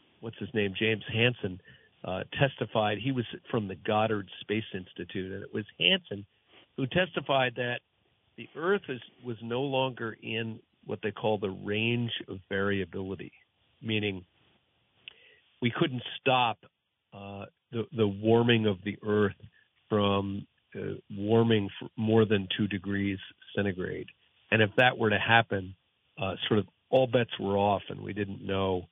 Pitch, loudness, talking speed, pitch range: 110 Hz, -29 LUFS, 145 wpm, 100-120 Hz